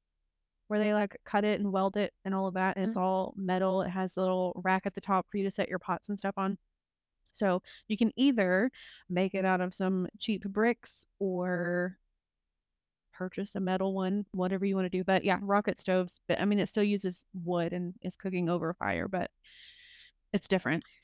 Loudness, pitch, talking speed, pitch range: -31 LUFS, 190 Hz, 210 wpm, 180-200 Hz